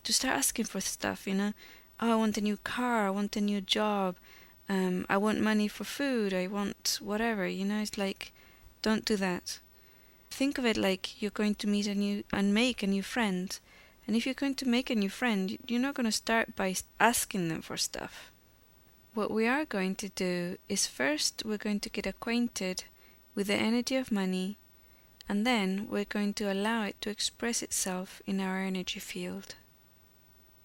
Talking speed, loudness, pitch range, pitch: 195 wpm, -31 LUFS, 195-225 Hz, 205 Hz